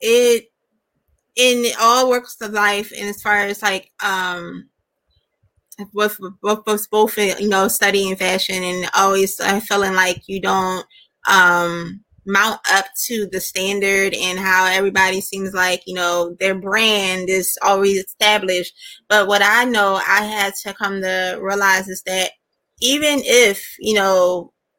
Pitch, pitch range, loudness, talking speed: 195 Hz, 185-210 Hz, -17 LUFS, 145 wpm